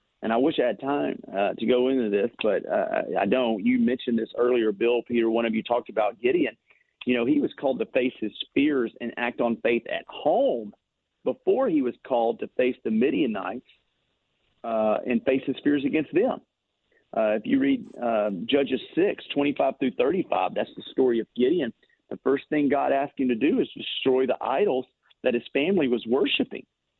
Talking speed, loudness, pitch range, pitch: 200 wpm, -25 LUFS, 120-145 Hz, 125 Hz